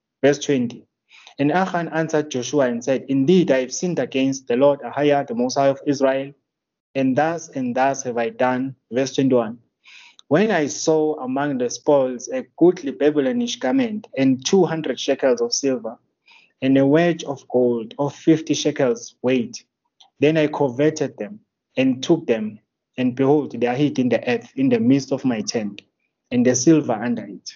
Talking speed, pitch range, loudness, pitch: 170 wpm, 125-150 Hz, -20 LUFS, 135 Hz